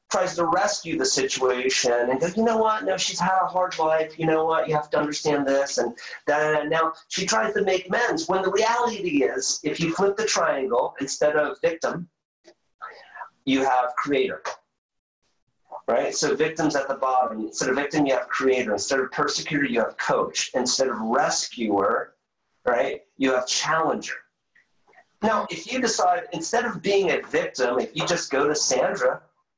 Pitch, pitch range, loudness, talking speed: 160 Hz, 135-195 Hz, -23 LUFS, 175 wpm